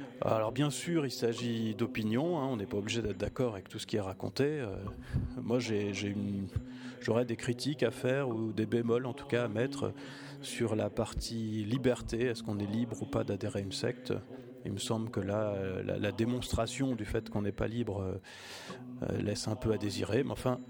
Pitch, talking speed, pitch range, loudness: 115 Hz, 210 wpm, 105-125 Hz, -35 LUFS